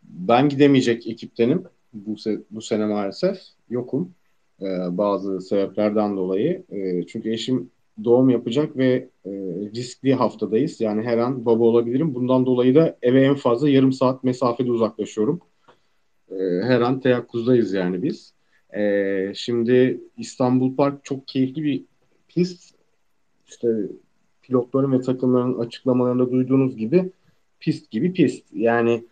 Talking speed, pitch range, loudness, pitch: 130 wpm, 105-130 Hz, -21 LUFS, 125 Hz